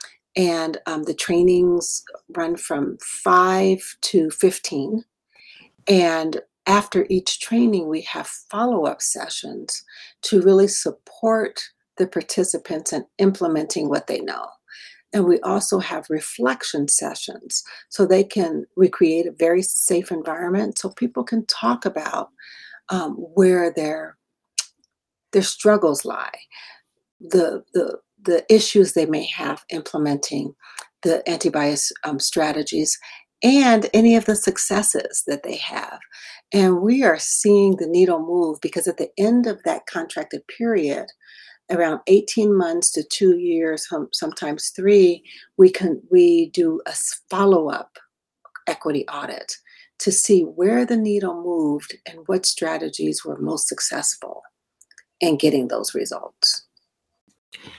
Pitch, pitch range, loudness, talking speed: 185 Hz, 165-215 Hz, -20 LUFS, 125 wpm